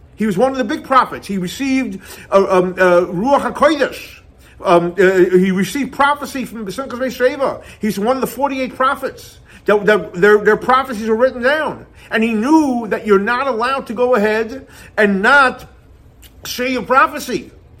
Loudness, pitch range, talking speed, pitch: -15 LUFS, 205-260 Hz, 160 wpm, 235 Hz